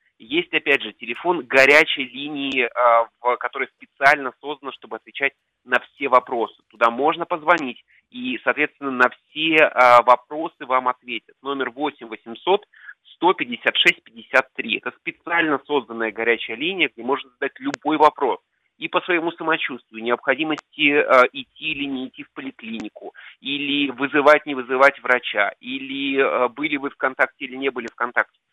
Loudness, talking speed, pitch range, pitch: -20 LUFS, 135 wpm, 125-155 Hz, 140 Hz